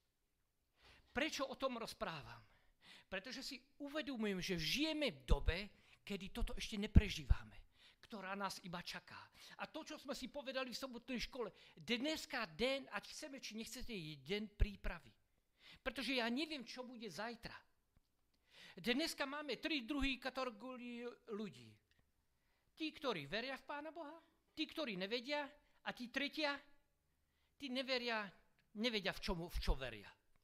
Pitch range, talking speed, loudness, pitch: 195-275 Hz, 135 wpm, -44 LUFS, 240 Hz